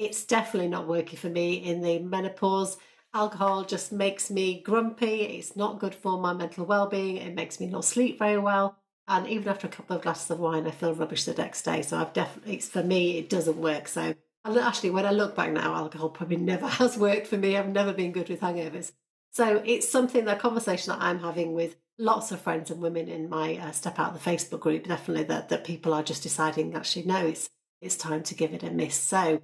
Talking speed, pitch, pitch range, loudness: 230 wpm, 180 Hz, 165-200 Hz, -28 LUFS